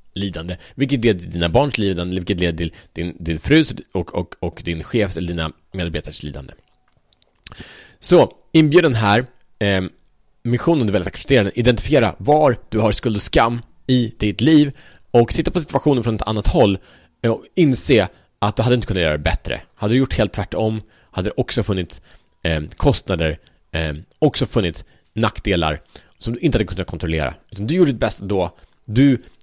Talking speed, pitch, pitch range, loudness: 180 wpm, 105 Hz, 85-125 Hz, -19 LUFS